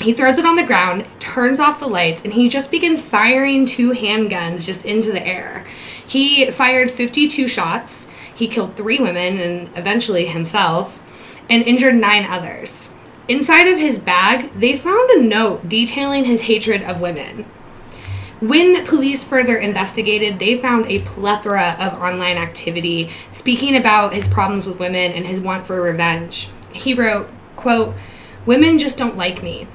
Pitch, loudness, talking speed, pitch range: 220 Hz, -15 LUFS, 160 wpm, 180-255 Hz